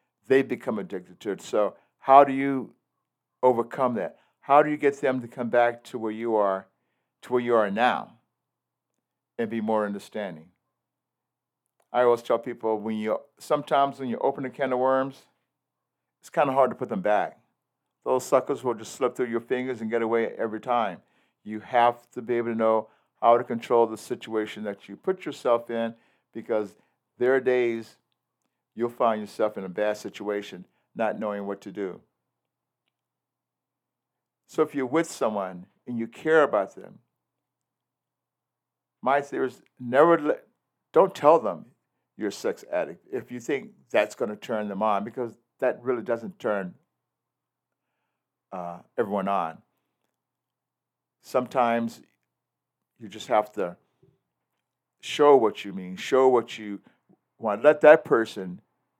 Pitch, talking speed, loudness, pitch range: 115 Hz, 160 wpm, -25 LUFS, 110-130 Hz